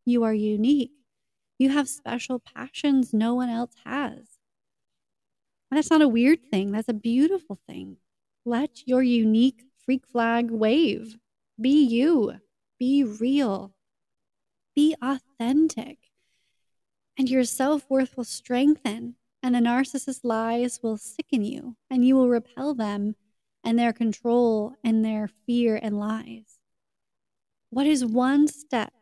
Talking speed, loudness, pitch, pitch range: 125 wpm, -24 LUFS, 245 Hz, 225-270 Hz